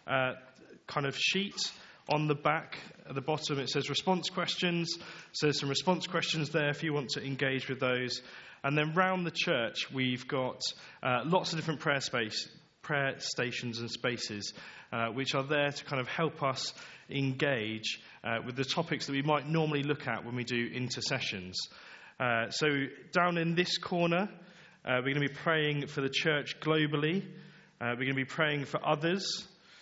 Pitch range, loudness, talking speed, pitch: 130-165 Hz, -32 LUFS, 185 wpm, 145 Hz